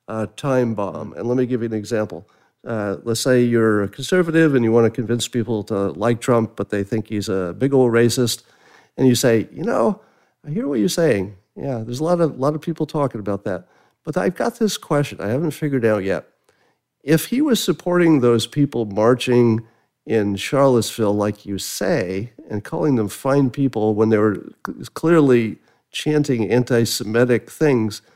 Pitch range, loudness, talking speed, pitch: 110-135 Hz, -19 LUFS, 190 wpm, 120 Hz